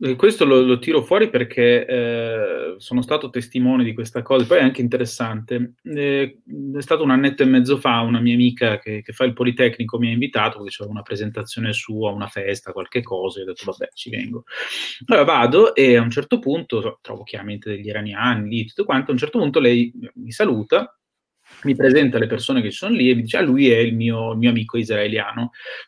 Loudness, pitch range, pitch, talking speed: -19 LUFS, 115-135 Hz, 120 Hz, 210 wpm